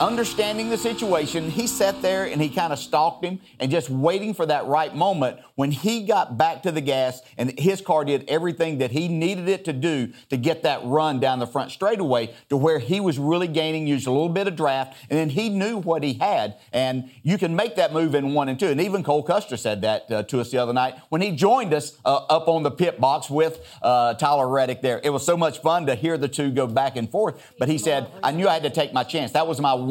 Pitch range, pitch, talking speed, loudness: 135-175 Hz, 155 Hz, 255 wpm, -23 LUFS